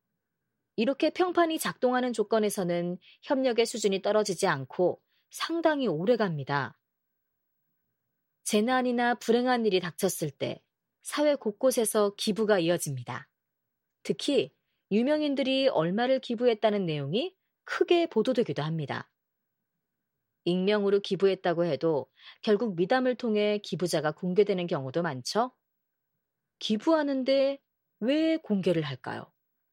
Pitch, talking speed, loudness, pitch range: 215 Hz, 270 characters per minute, -28 LUFS, 180-255 Hz